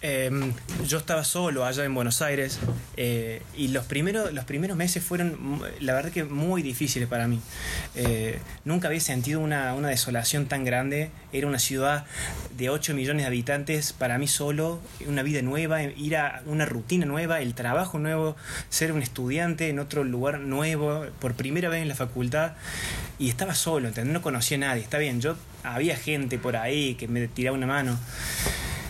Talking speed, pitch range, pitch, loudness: 180 wpm, 125-155 Hz, 140 Hz, -27 LUFS